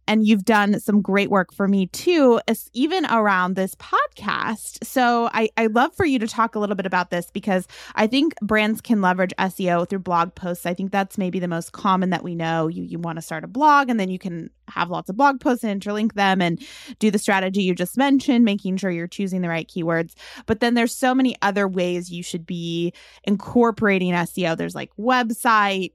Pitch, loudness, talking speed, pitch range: 200 Hz, -21 LUFS, 215 wpm, 180-230 Hz